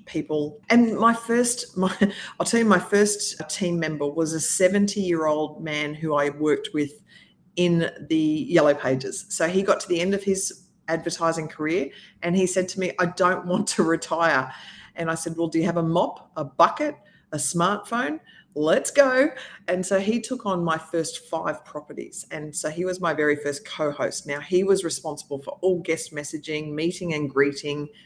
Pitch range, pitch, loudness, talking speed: 155-195 Hz, 170 Hz, -24 LUFS, 185 wpm